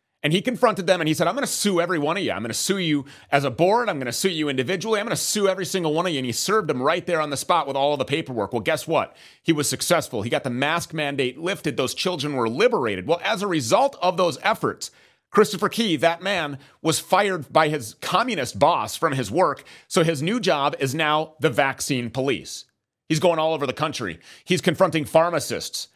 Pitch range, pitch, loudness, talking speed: 140-185 Hz, 160 Hz, -22 LUFS, 235 wpm